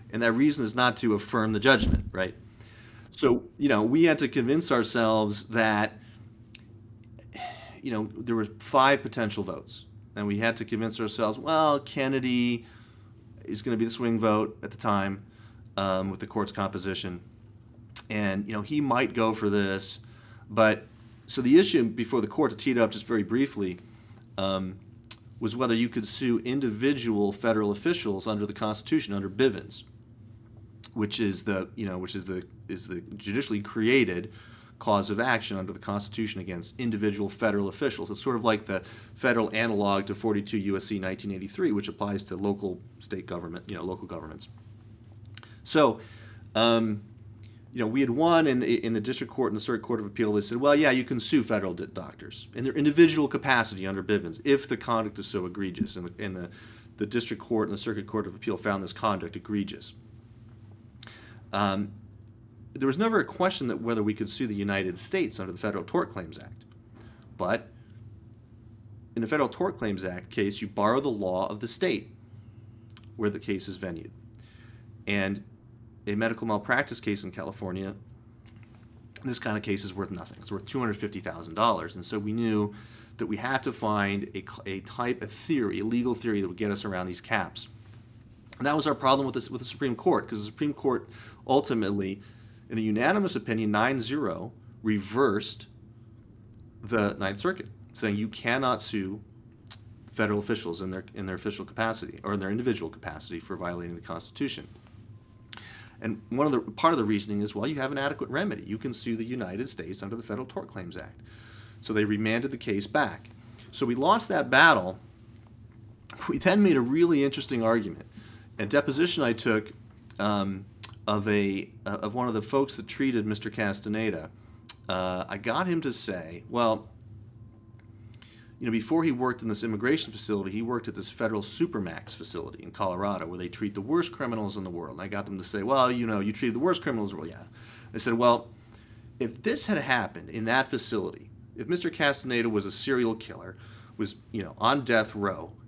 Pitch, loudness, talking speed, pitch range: 110 Hz, -28 LUFS, 185 wpm, 105-115 Hz